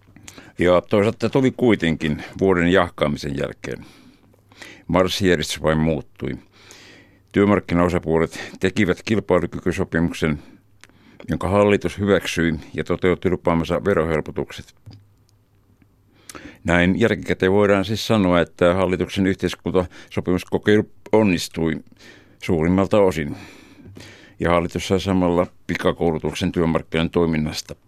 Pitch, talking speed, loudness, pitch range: 90 Hz, 80 wpm, -20 LUFS, 85-100 Hz